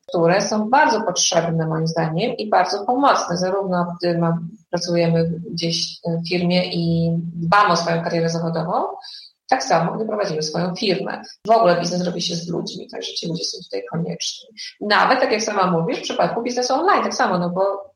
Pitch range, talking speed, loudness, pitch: 170-215 Hz, 175 wpm, -20 LUFS, 180 Hz